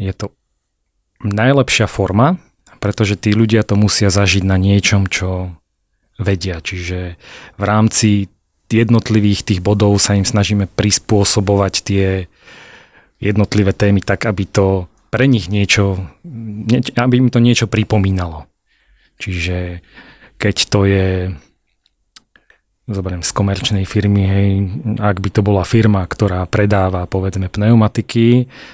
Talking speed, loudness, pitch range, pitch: 120 wpm, -14 LUFS, 95-110 Hz, 100 Hz